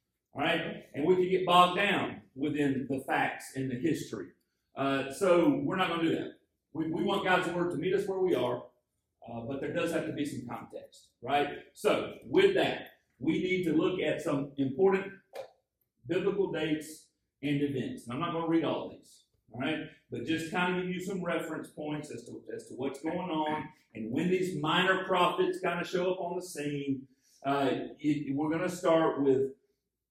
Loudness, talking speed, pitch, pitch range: -31 LUFS, 200 wpm, 160 Hz, 140-180 Hz